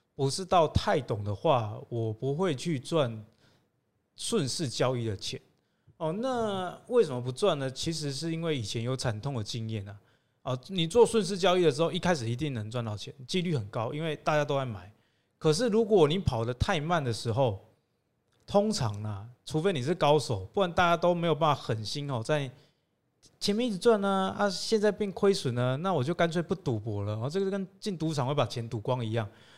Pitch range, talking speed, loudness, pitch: 120-180 Hz, 285 characters per minute, -29 LUFS, 145 Hz